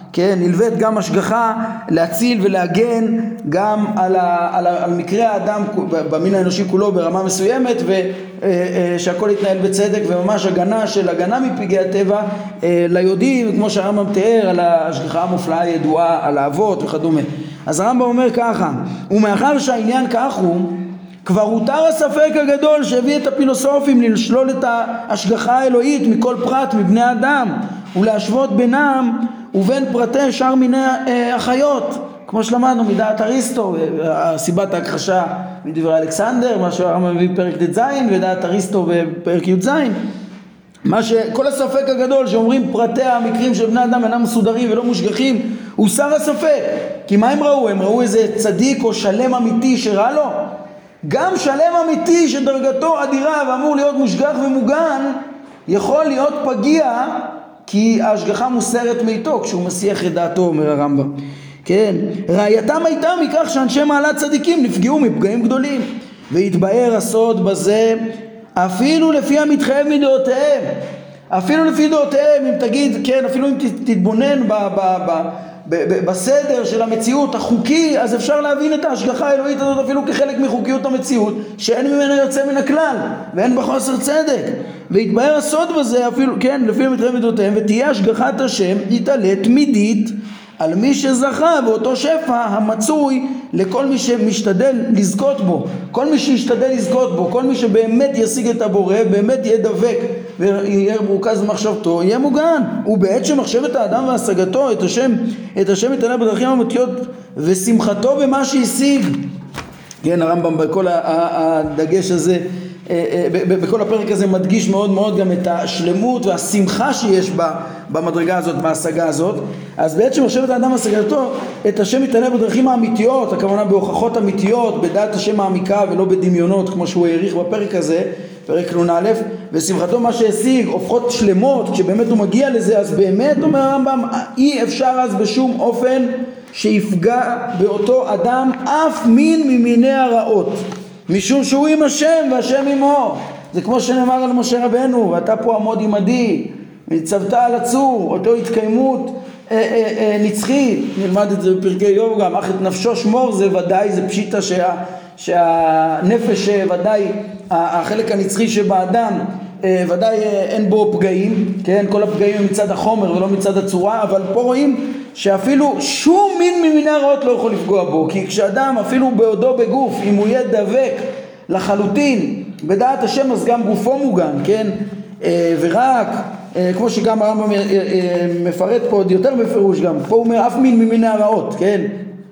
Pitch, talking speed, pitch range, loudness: 225 Hz, 140 wpm, 195-260 Hz, -15 LUFS